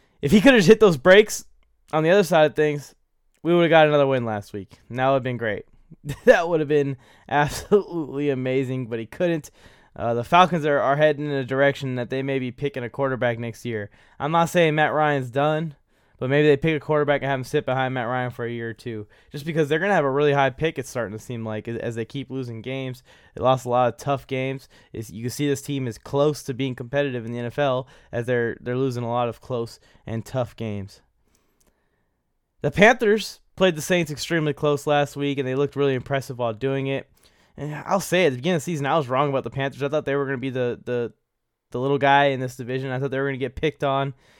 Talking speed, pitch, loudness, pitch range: 245 wpm, 135 Hz, -22 LUFS, 125-150 Hz